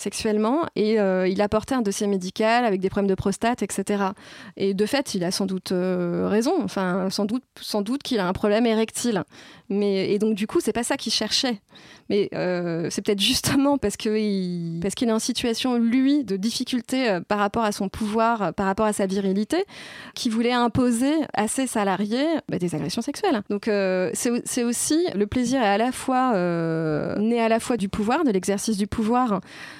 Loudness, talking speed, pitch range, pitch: -23 LUFS, 205 wpm, 195-245 Hz, 215 Hz